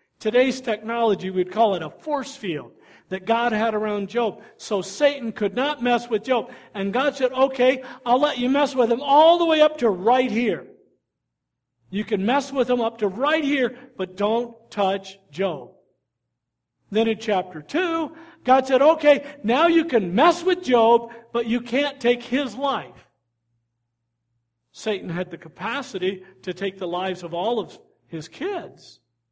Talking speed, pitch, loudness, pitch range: 170 wpm, 230 Hz, -22 LUFS, 195-265 Hz